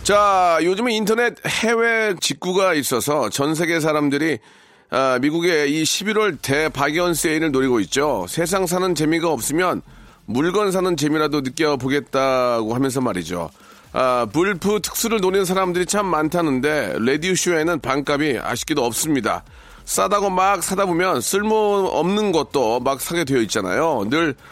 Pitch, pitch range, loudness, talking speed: 170 Hz, 145-195 Hz, -19 LUFS, 315 characters per minute